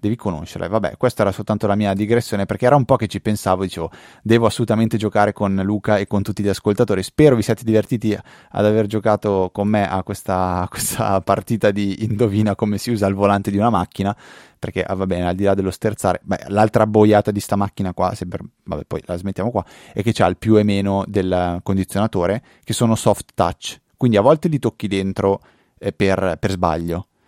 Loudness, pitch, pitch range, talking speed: -19 LUFS, 100 Hz, 95-110 Hz, 210 wpm